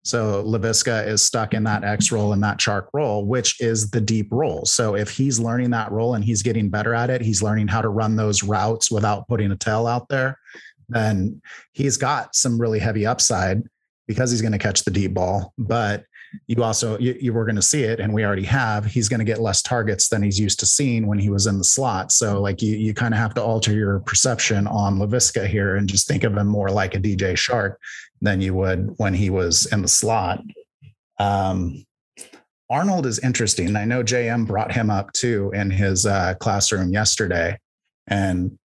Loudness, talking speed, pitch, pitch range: -20 LUFS, 215 wpm, 110 Hz, 100-115 Hz